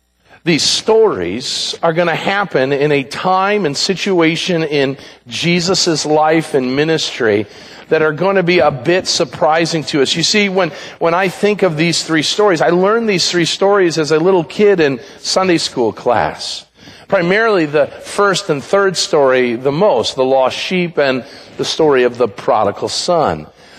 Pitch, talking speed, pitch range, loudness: 170 Hz, 170 wpm, 150-190 Hz, -14 LUFS